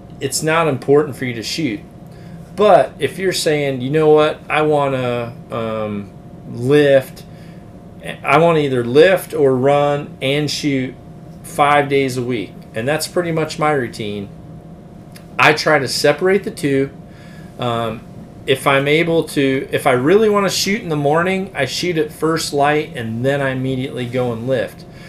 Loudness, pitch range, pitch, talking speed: -16 LUFS, 135-170 Hz, 150 Hz, 160 wpm